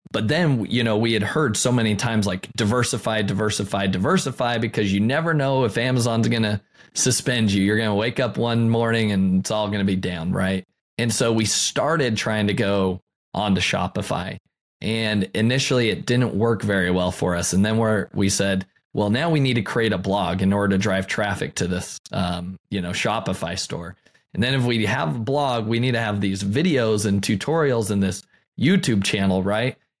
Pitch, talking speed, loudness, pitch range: 110 Hz, 205 wpm, -21 LUFS, 100-120 Hz